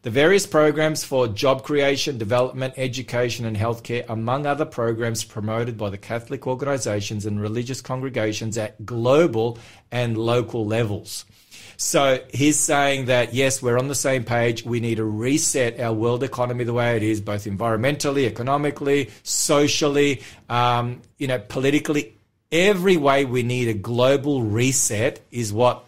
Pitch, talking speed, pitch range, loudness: 120 Hz, 150 wpm, 115-140 Hz, -22 LUFS